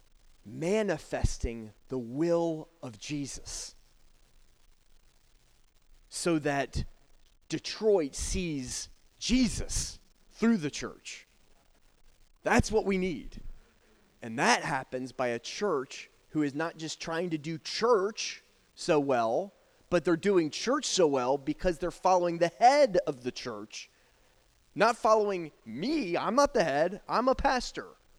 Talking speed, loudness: 120 wpm, -30 LUFS